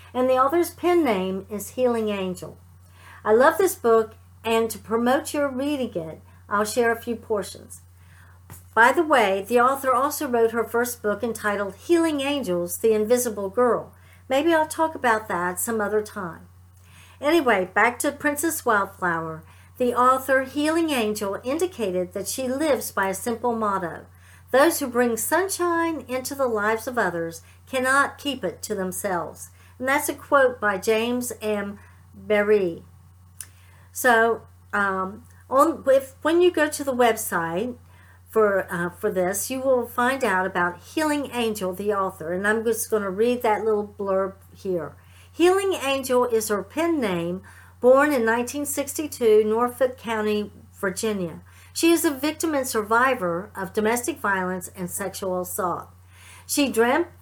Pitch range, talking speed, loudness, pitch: 180-265 Hz, 150 wpm, -23 LUFS, 220 Hz